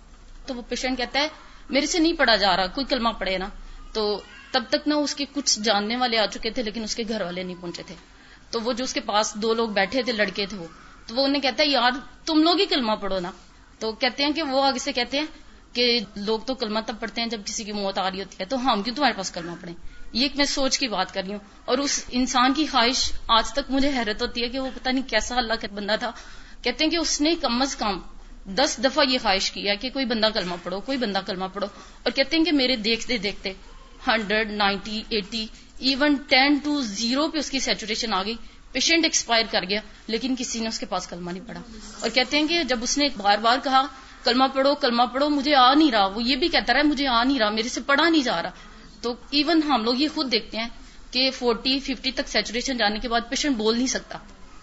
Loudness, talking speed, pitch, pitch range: -23 LUFS, 235 wpm, 245 Hz, 215-275 Hz